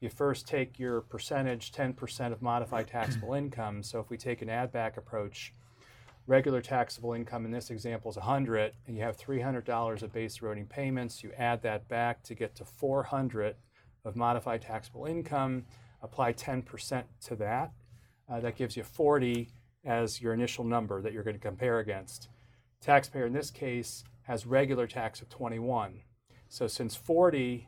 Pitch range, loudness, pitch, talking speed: 115-125 Hz, -33 LUFS, 120 Hz, 165 wpm